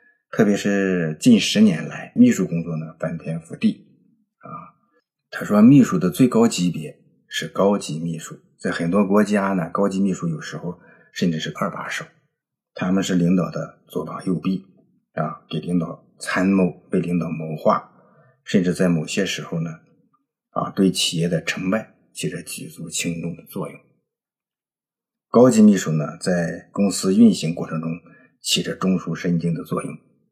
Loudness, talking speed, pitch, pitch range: -21 LUFS, 230 characters per minute, 90 Hz, 85-115 Hz